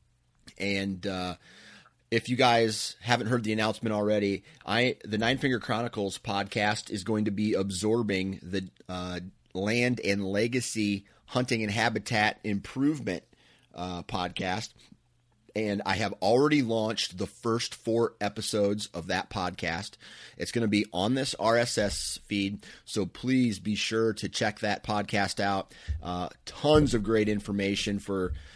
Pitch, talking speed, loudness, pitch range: 105 Hz, 140 wpm, -29 LUFS, 95-115 Hz